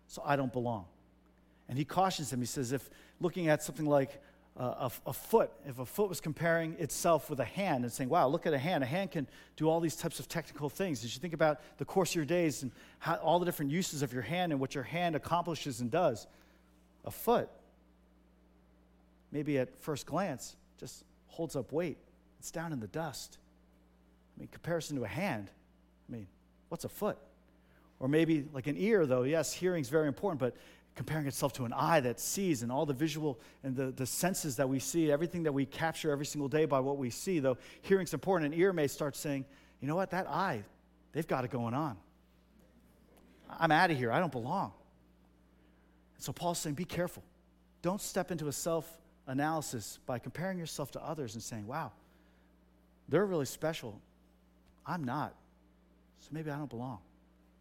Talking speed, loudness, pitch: 200 wpm, -35 LUFS, 140 Hz